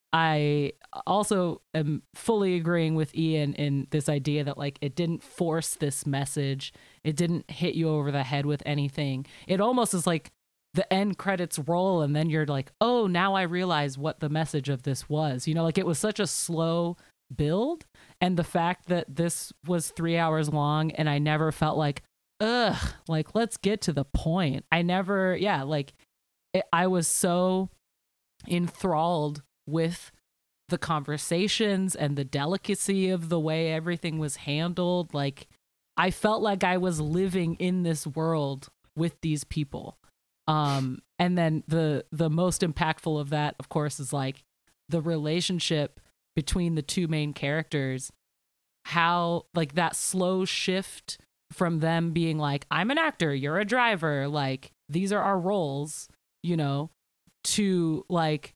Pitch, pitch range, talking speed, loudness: 160 Hz, 145-180 Hz, 160 wpm, -28 LUFS